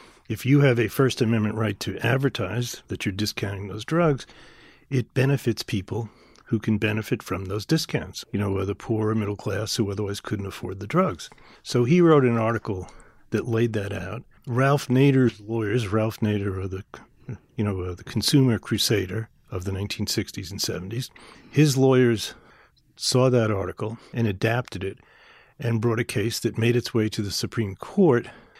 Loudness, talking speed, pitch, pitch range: -24 LUFS, 170 wpm, 115 Hz, 105-125 Hz